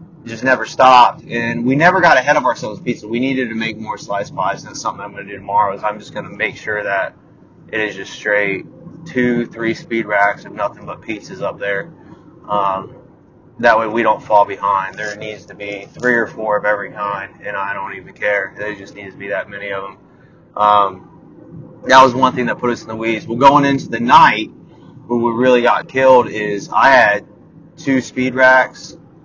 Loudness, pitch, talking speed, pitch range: -15 LUFS, 115 Hz, 215 wpm, 105-130 Hz